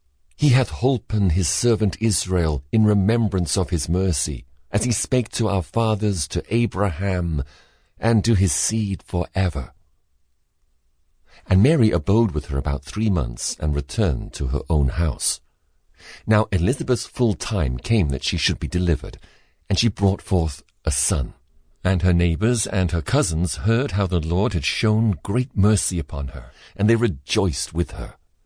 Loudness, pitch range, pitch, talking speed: -21 LUFS, 80-105 Hz, 90 Hz, 160 wpm